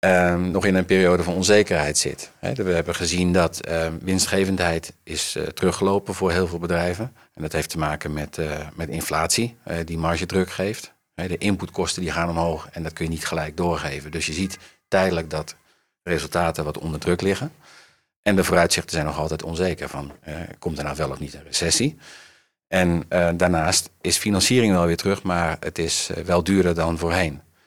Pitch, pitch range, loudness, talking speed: 85 Hz, 80-95 Hz, -22 LUFS, 200 wpm